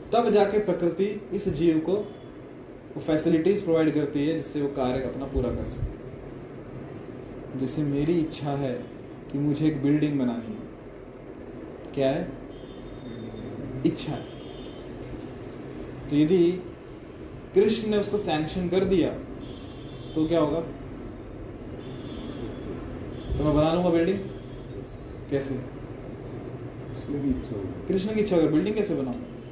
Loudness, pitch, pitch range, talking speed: -27 LUFS, 145 Hz, 130-170 Hz, 115 wpm